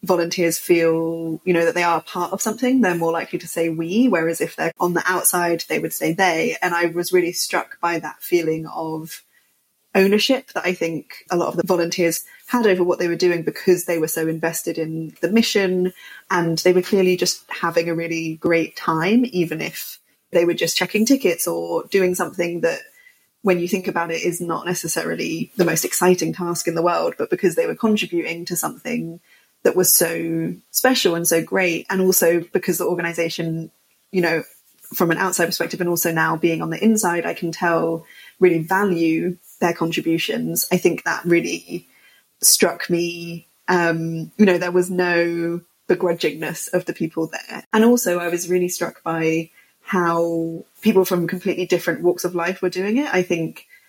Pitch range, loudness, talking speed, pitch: 165-185 Hz, -20 LUFS, 190 wpm, 175 Hz